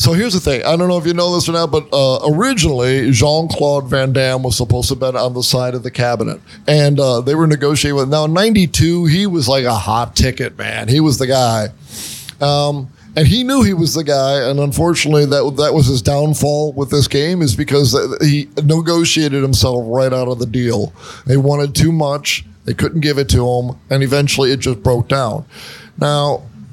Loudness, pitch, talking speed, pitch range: -14 LUFS, 140 Hz, 215 wpm, 130-155 Hz